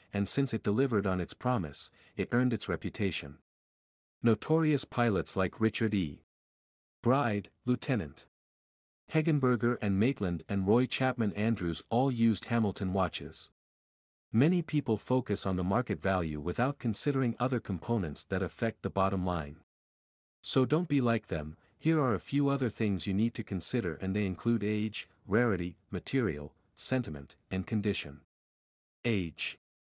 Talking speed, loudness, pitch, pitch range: 140 wpm, -32 LUFS, 105 Hz, 90-120 Hz